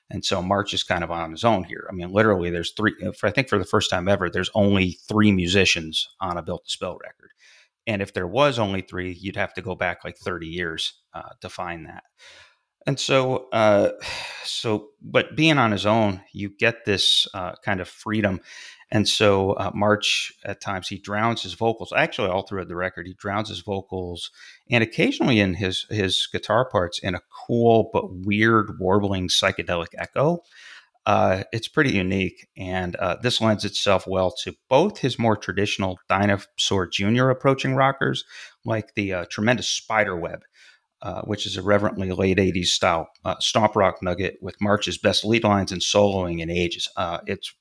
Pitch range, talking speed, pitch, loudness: 95-110 Hz, 190 wpm, 100 Hz, -22 LUFS